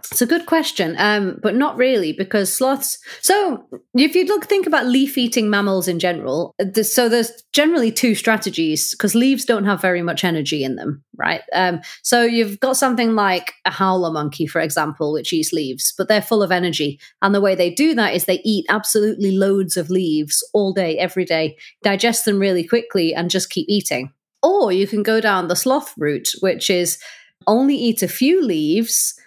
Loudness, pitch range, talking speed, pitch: -18 LUFS, 180-245 Hz, 195 wpm, 205 Hz